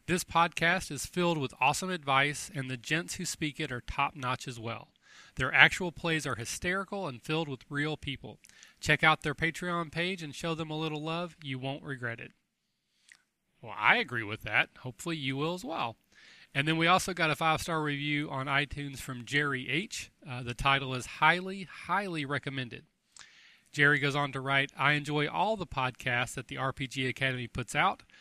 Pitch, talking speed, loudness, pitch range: 145 Hz, 190 wpm, -30 LUFS, 135-165 Hz